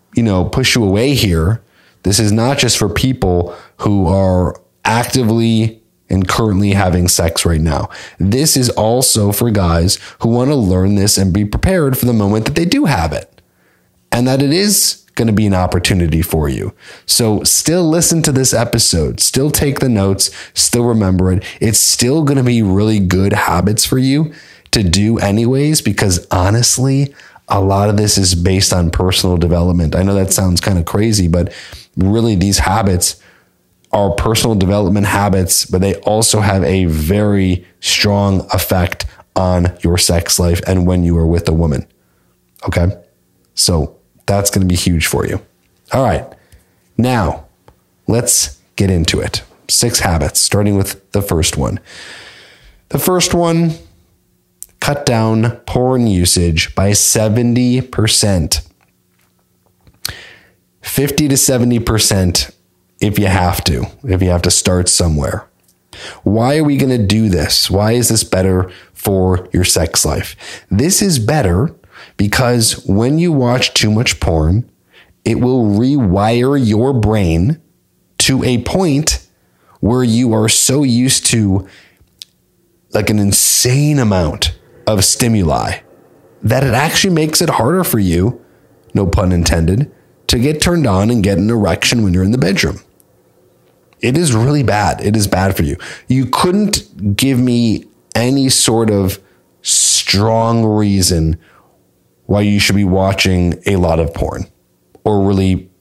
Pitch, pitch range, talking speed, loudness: 100 Hz, 90-120 Hz, 150 wpm, -13 LUFS